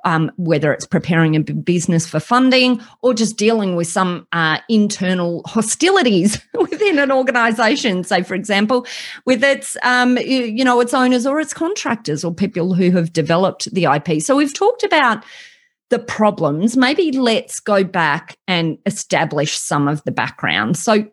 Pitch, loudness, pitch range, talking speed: 210 Hz, -16 LUFS, 170-255 Hz, 160 wpm